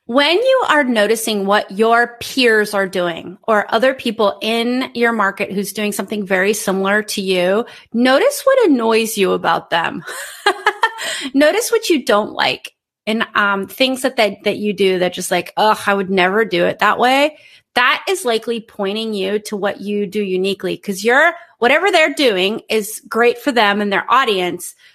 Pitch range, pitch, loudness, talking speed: 200-260 Hz, 220 Hz, -16 LUFS, 180 wpm